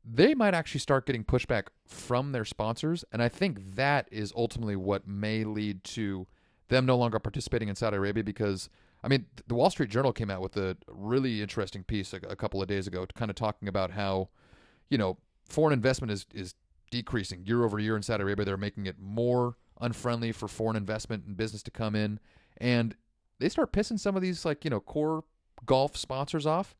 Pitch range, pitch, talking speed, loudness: 100-130 Hz, 110 Hz, 205 wpm, -31 LUFS